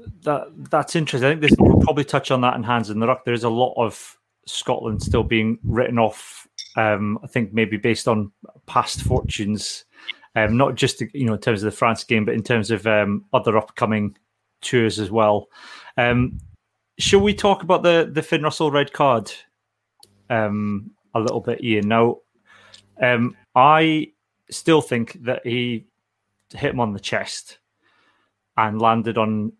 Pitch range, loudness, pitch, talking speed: 110-130 Hz, -20 LUFS, 115 Hz, 175 wpm